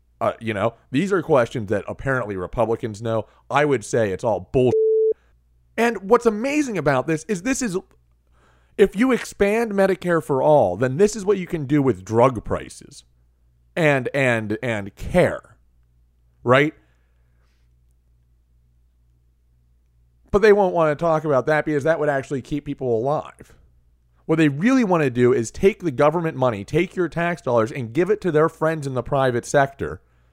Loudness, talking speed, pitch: -21 LUFS, 170 wpm, 130 Hz